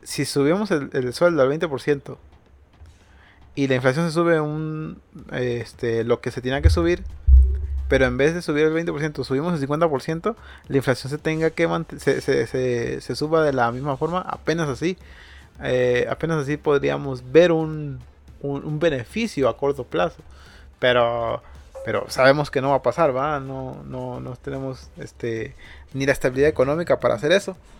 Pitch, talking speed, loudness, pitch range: 135 Hz, 170 wpm, -22 LUFS, 120-155 Hz